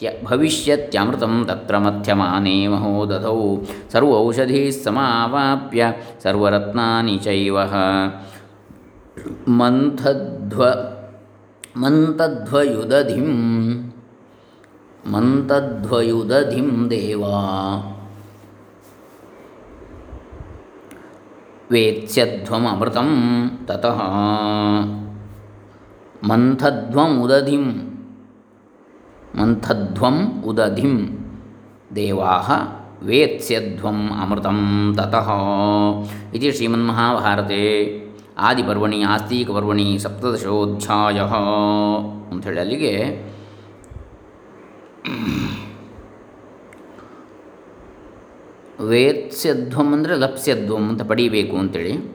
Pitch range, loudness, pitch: 100-120 Hz, -19 LUFS, 105 Hz